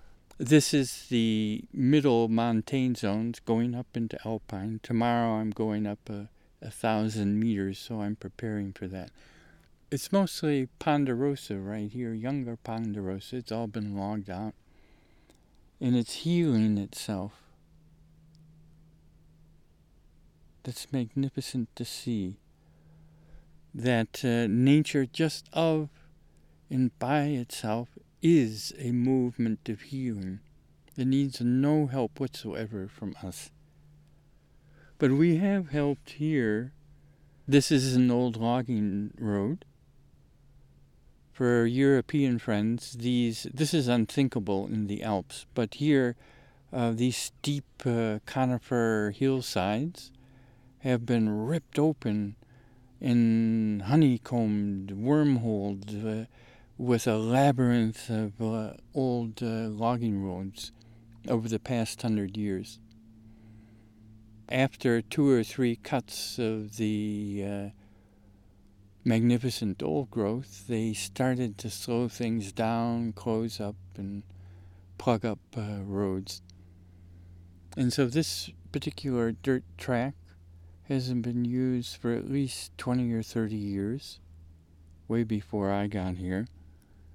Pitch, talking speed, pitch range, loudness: 115 Hz, 110 wpm, 100-130 Hz, -29 LUFS